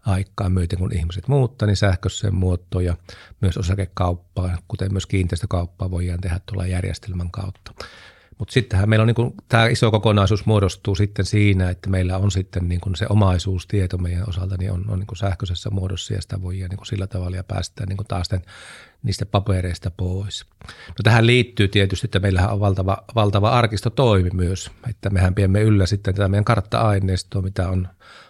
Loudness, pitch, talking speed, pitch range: -21 LUFS, 95 Hz, 175 wpm, 95-105 Hz